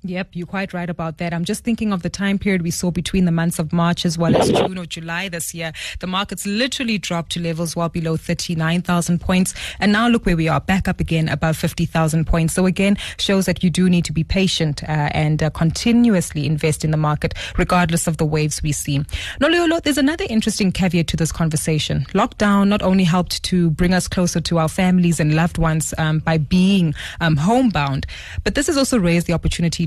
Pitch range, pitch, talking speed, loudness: 160-190 Hz, 175 Hz, 215 wpm, -19 LUFS